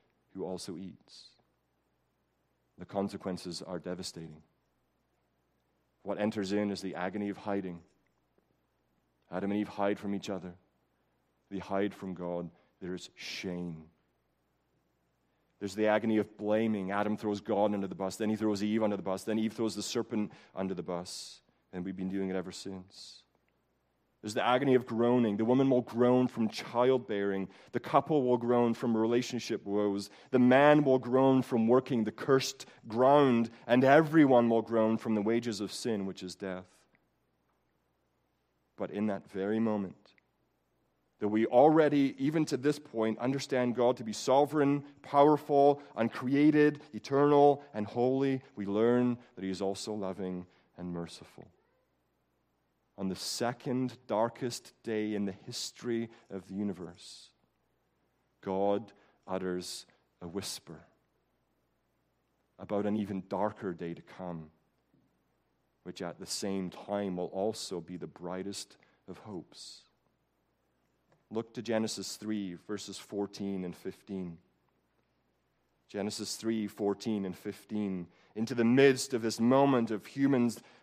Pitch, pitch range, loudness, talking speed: 100 Hz, 90-120 Hz, -31 LUFS, 140 wpm